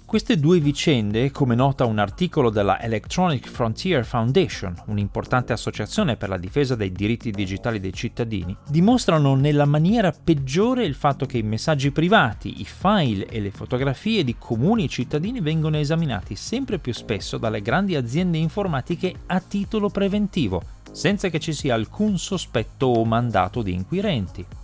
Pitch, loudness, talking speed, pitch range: 140 Hz, -22 LUFS, 150 wpm, 110-180 Hz